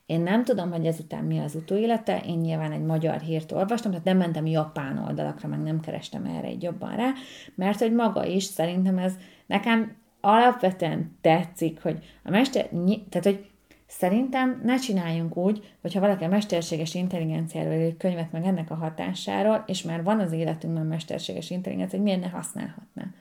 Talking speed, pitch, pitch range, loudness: 175 wpm, 180 Hz, 160-205 Hz, -26 LUFS